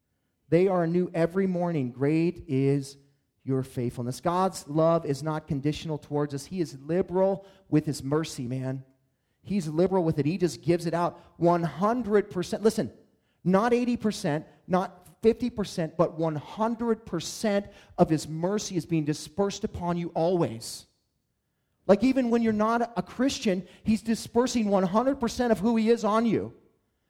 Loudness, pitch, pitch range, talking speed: -27 LUFS, 175 Hz, 150-205 Hz, 145 wpm